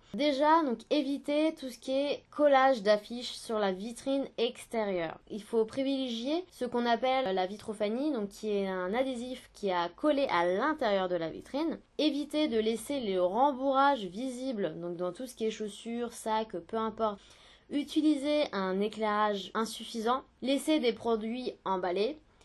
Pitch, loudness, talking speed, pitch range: 235 Hz, -31 LUFS, 155 wpm, 210-275 Hz